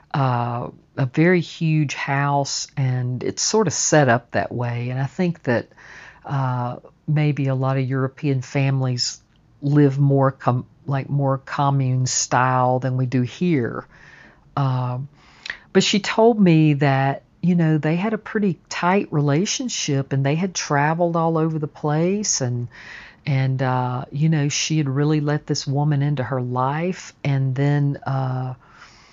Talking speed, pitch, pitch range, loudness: 150 wpm, 140 Hz, 130-155 Hz, -21 LUFS